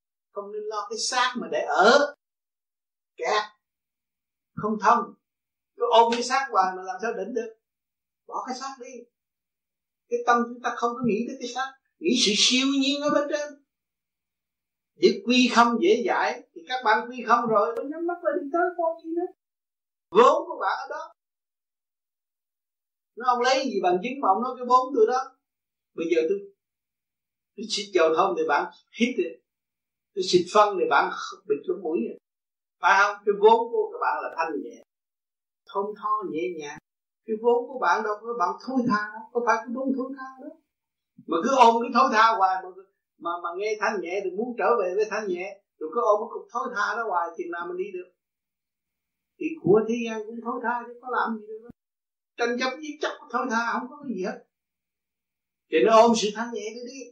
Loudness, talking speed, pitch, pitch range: -24 LUFS, 200 wpm, 235 Hz, 210-270 Hz